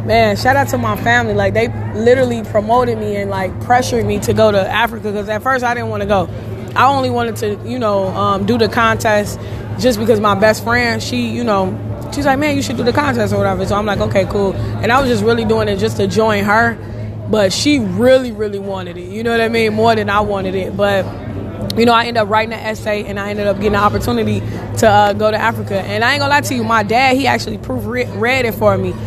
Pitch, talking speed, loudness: 200 Hz, 255 wpm, -15 LUFS